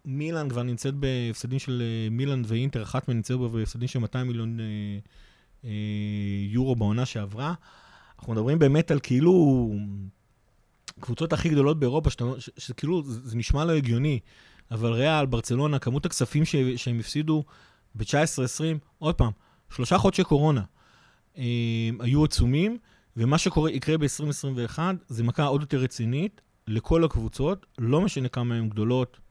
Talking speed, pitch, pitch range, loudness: 145 wpm, 125 Hz, 115-150 Hz, -26 LUFS